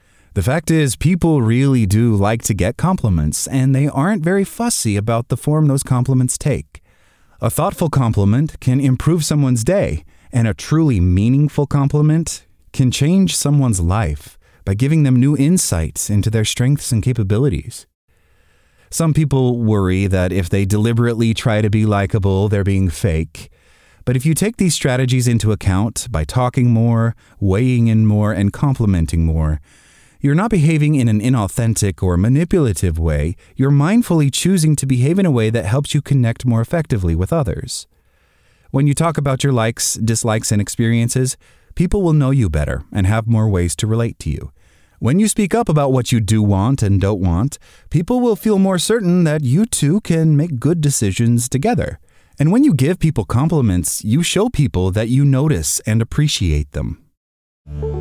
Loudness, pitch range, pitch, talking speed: -16 LUFS, 100-150 Hz, 120 Hz, 170 wpm